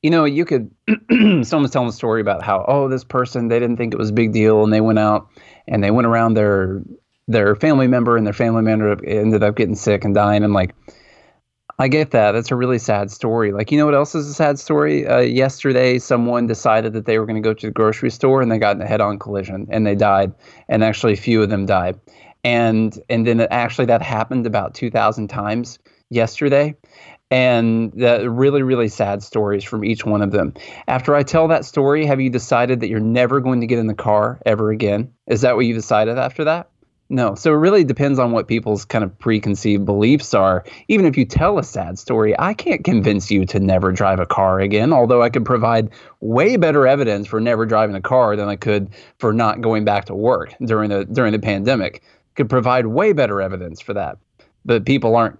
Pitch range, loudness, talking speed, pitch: 105-125 Hz, -17 LUFS, 225 wpm, 115 Hz